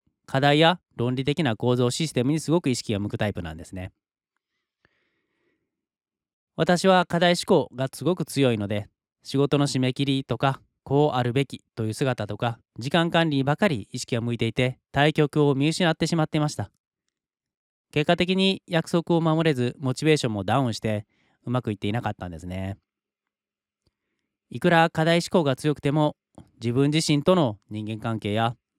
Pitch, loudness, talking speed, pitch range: 135 Hz, -24 LUFS, 330 characters per minute, 115-160 Hz